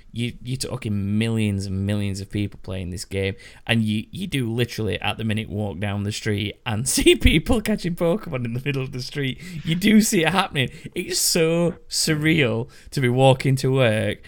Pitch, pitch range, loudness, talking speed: 125 Hz, 105-160 Hz, -22 LUFS, 200 wpm